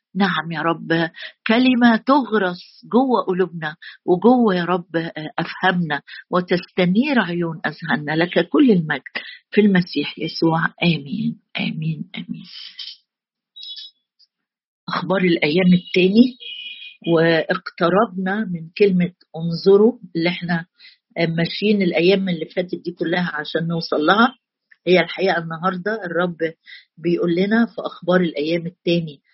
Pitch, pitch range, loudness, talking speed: 180 Hz, 165-205 Hz, -19 LUFS, 105 wpm